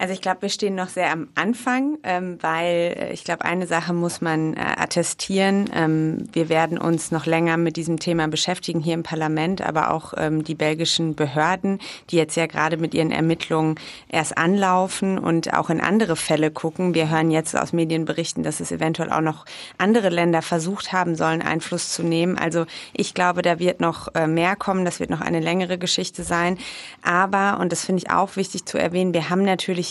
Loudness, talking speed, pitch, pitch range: -22 LUFS, 190 wpm, 170 Hz, 160-185 Hz